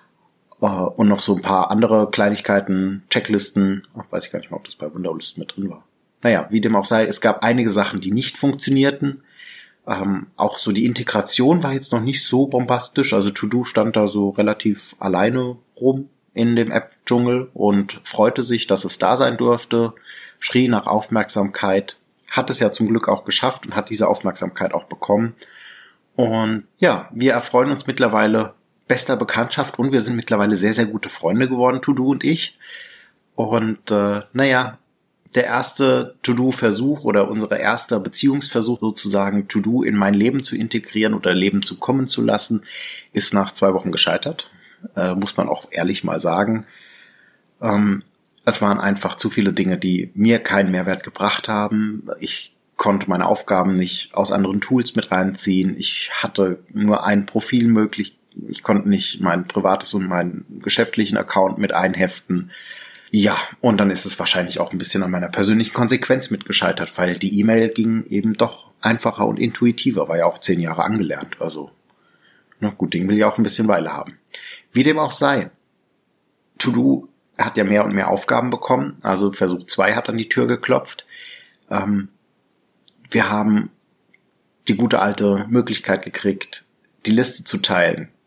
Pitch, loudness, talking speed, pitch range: 105 Hz, -19 LUFS, 170 wpm, 100-120 Hz